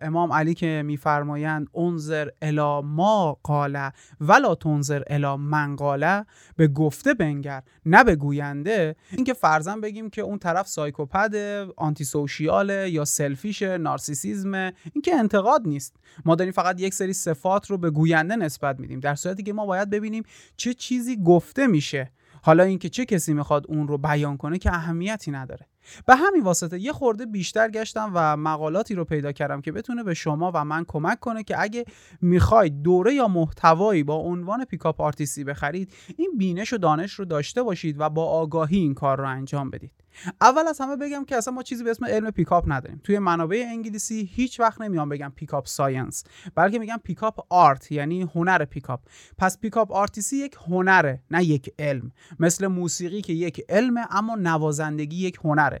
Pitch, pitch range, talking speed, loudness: 170 Hz, 150-205 Hz, 170 wpm, -23 LUFS